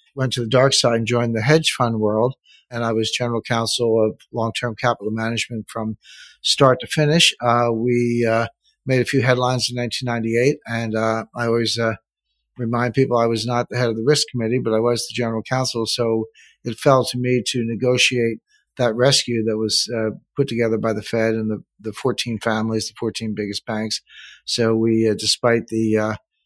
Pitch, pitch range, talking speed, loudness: 115 Hz, 110-125 Hz, 200 wpm, -20 LUFS